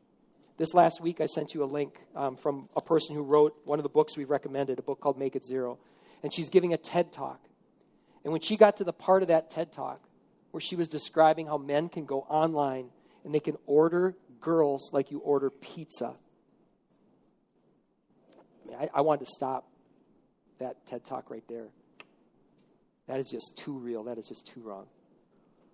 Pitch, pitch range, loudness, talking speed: 150 Hz, 140-160 Hz, -29 LUFS, 195 wpm